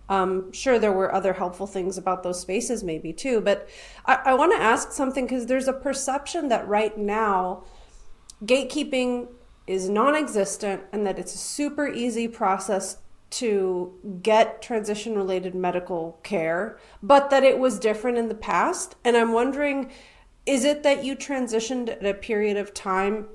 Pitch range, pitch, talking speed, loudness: 190-255 Hz, 215 Hz, 165 wpm, -24 LUFS